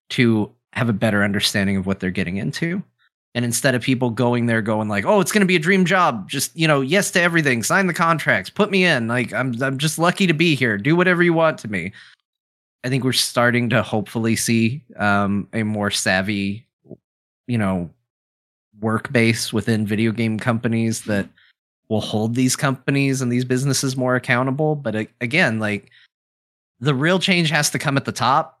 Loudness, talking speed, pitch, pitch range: -19 LUFS, 195 wpm, 120 Hz, 105-150 Hz